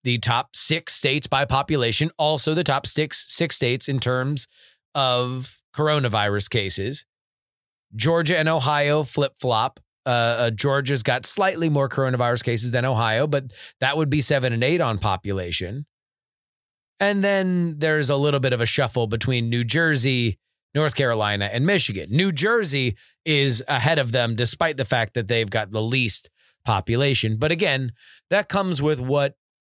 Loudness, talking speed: -21 LUFS, 160 wpm